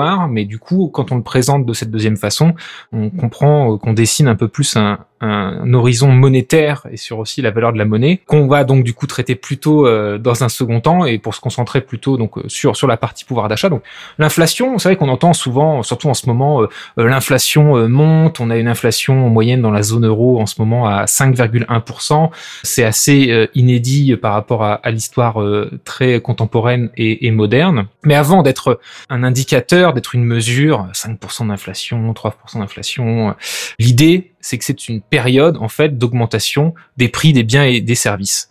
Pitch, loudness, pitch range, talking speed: 125 Hz, -14 LUFS, 115-145 Hz, 185 wpm